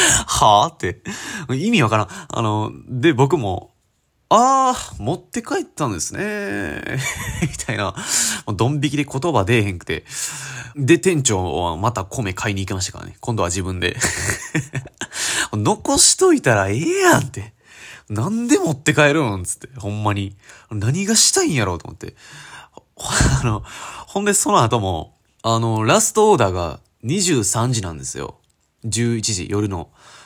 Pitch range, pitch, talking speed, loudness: 100-170 Hz, 115 Hz, 280 characters per minute, -18 LUFS